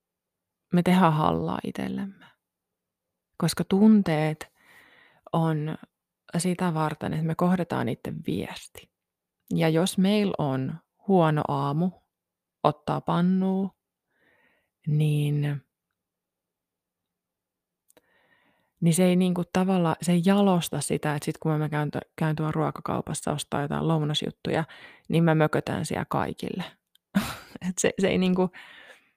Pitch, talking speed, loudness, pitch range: 165 Hz, 115 wpm, -26 LUFS, 155-185 Hz